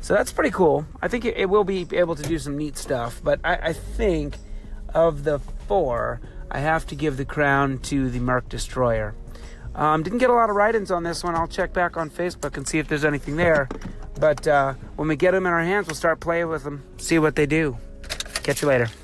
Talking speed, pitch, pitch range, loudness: 235 wpm, 155 Hz, 135-170 Hz, -23 LUFS